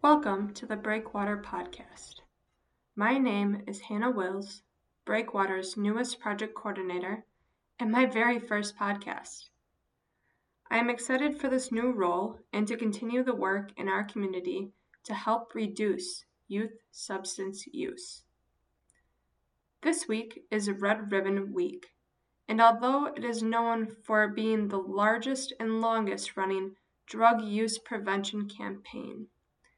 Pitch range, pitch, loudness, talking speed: 195-235 Hz, 215 Hz, -31 LUFS, 125 wpm